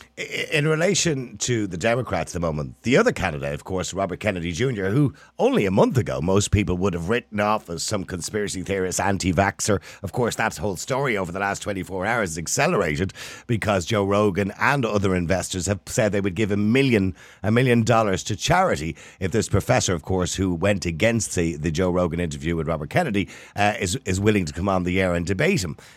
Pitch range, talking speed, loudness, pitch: 90-105 Hz, 210 wpm, -23 LUFS, 100 Hz